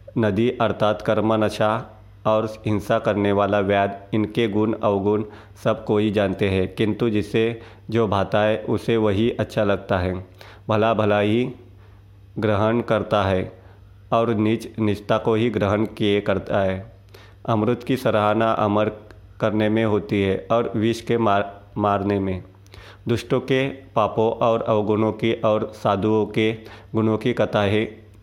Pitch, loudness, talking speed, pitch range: 105 Hz, -21 LUFS, 140 wpm, 100-110 Hz